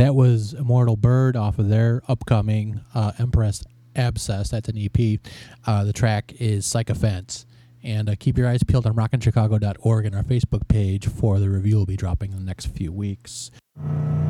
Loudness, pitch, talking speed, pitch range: -22 LUFS, 110 Hz, 180 wpm, 105-120 Hz